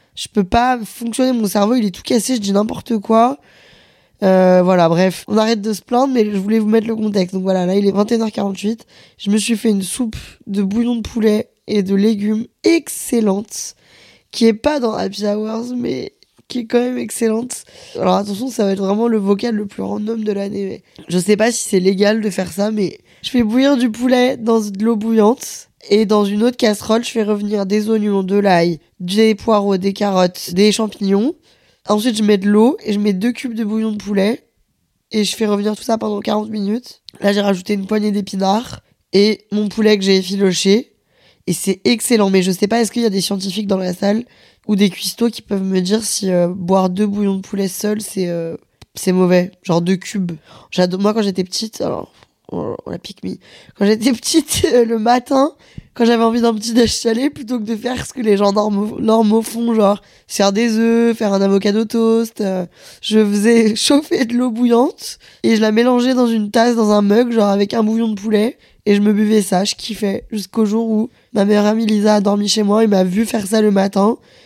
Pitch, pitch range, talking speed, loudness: 215 Hz, 200-230 Hz, 220 wpm, -16 LUFS